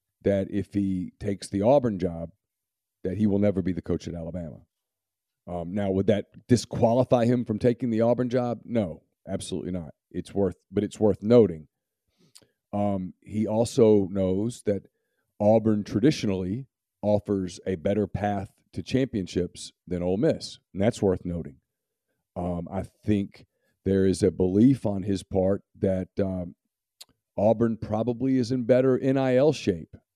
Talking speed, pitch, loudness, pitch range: 150 wpm, 100 Hz, -26 LUFS, 95-115 Hz